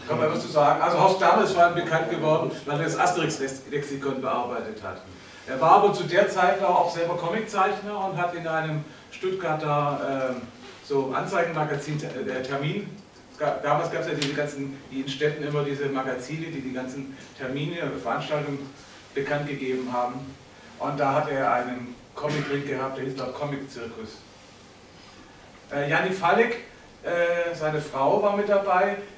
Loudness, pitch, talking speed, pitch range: -25 LUFS, 145 Hz, 160 wpm, 135-170 Hz